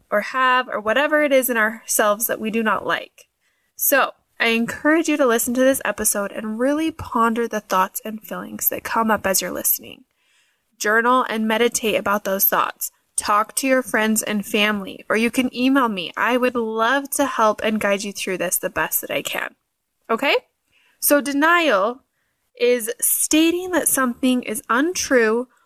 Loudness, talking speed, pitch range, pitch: -19 LUFS, 180 wpm, 215-270 Hz, 235 Hz